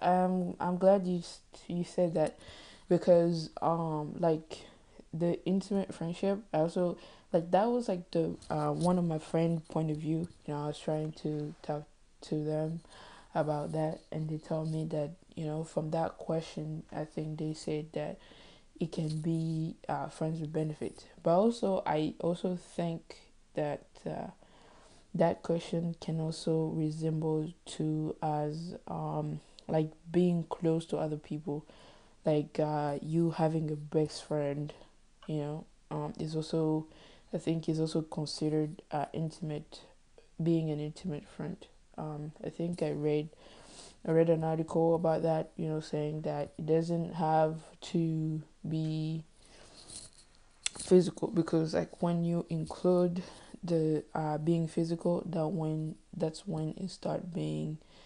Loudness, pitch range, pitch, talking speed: -33 LUFS, 155-170 Hz, 160 Hz, 145 wpm